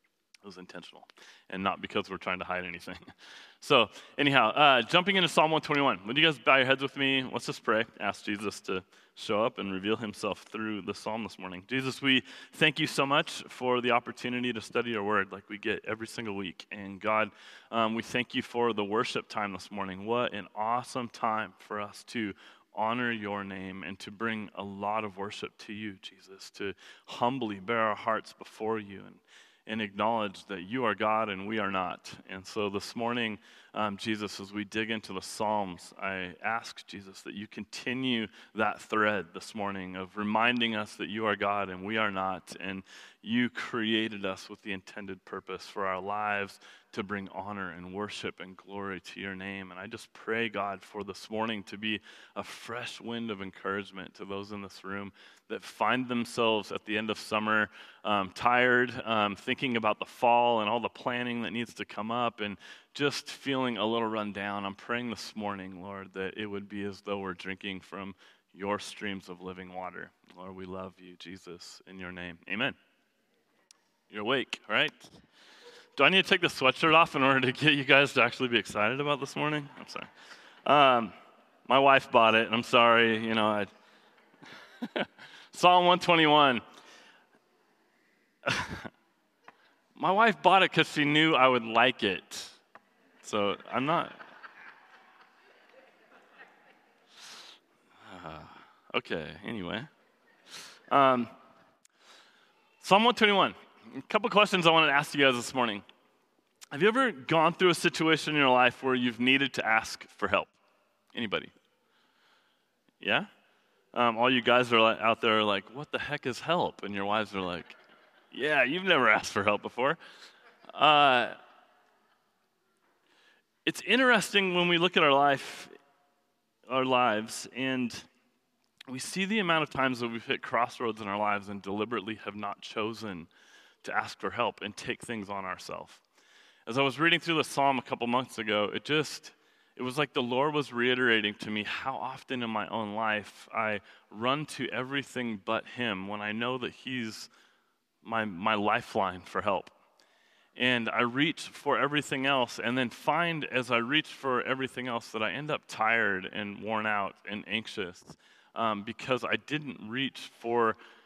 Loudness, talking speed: -29 LUFS, 175 wpm